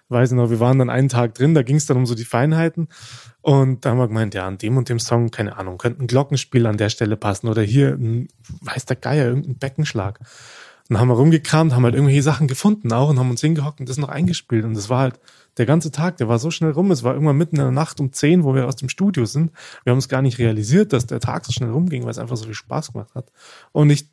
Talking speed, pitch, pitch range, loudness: 280 wpm, 130 Hz, 120-150 Hz, -19 LUFS